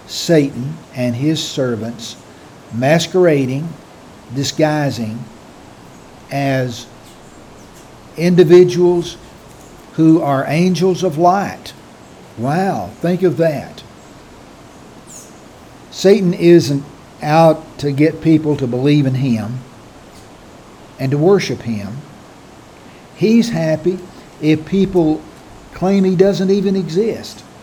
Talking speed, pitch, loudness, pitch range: 85 wpm, 155 Hz, -15 LUFS, 135-180 Hz